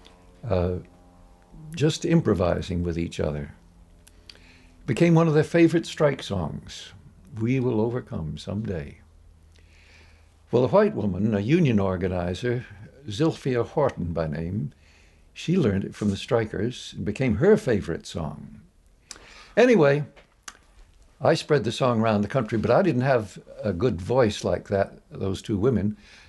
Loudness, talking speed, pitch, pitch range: -24 LUFS, 135 wpm, 100 Hz, 85-125 Hz